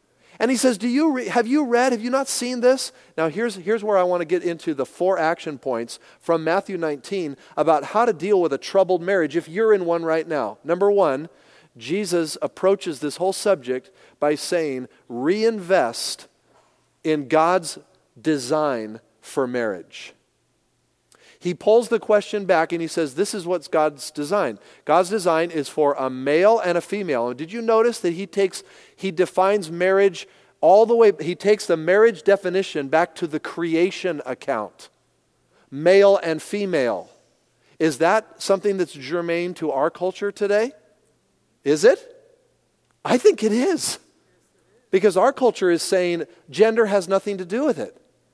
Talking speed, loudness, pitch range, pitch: 165 wpm, -21 LUFS, 160-210 Hz, 185 Hz